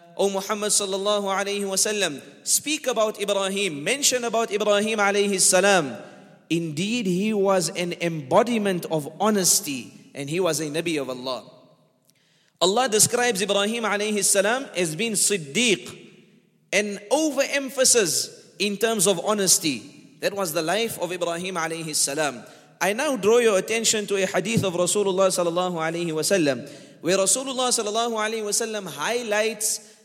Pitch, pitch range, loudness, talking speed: 200 Hz, 180-220 Hz, -22 LUFS, 125 wpm